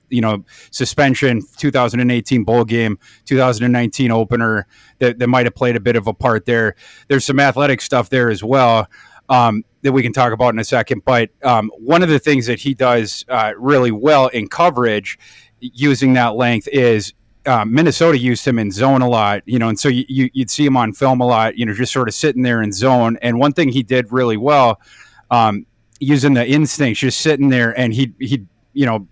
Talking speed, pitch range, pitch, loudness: 210 wpm, 115-135 Hz, 125 Hz, -15 LUFS